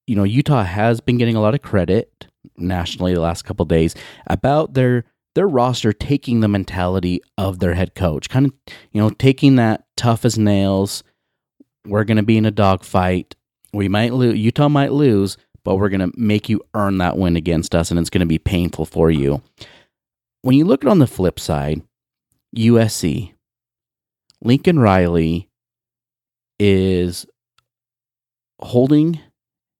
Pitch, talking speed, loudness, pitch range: 105 Hz, 160 wpm, -17 LUFS, 90-120 Hz